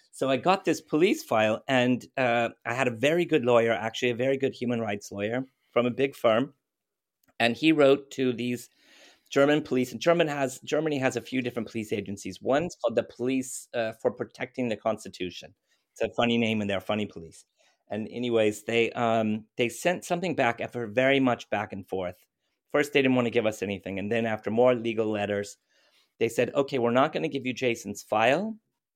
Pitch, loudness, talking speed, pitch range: 120 Hz, -27 LUFS, 200 wpm, 110-135 Hz